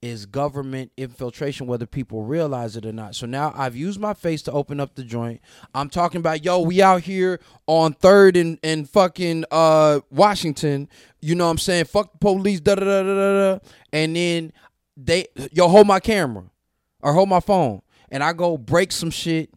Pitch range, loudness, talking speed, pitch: 135-185 Hz, -19 LUFS, 180 wpm, 160 Hz